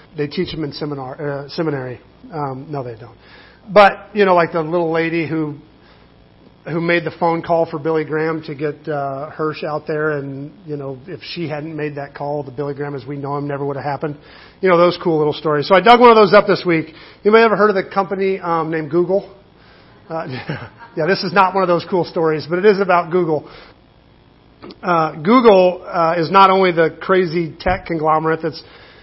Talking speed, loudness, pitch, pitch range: 215 wpm, -16 LUFS, 160 Hz, 150-180 Hz